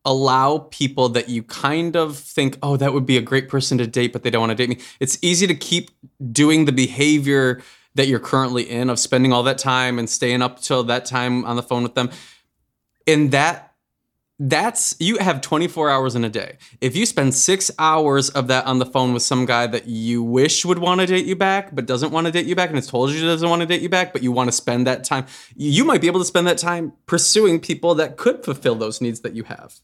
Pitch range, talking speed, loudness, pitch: 125-165 Hz, 250 wpm, -19 LUFS, 135 Hz